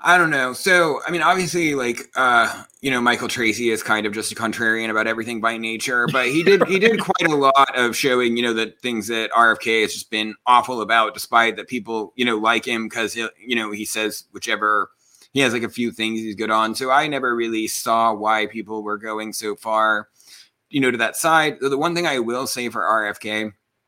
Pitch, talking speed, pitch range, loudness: 115 Hz, 230 wpm, 110-125 Hz, -19 LUFS